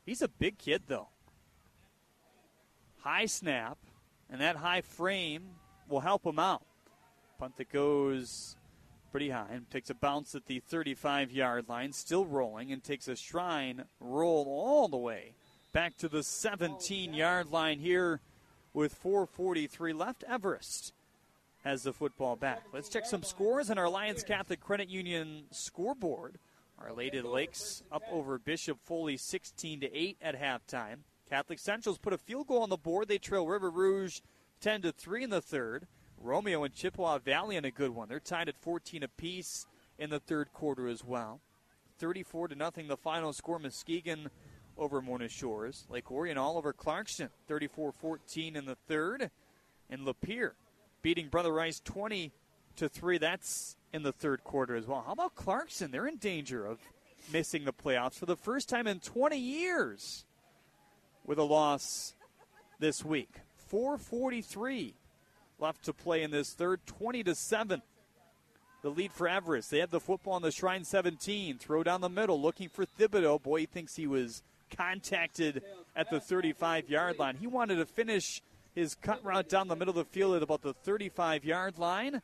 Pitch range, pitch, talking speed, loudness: 140-185 Hz, 165 Hz, 165 wpm, -35 LUFS